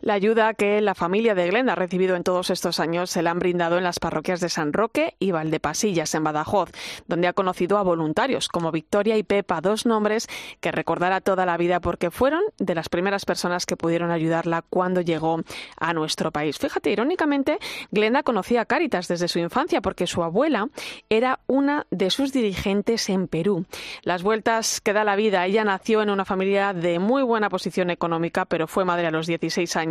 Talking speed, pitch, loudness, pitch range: 200 wpm, 185 Hz, -23 LUFS, 170-215 Hz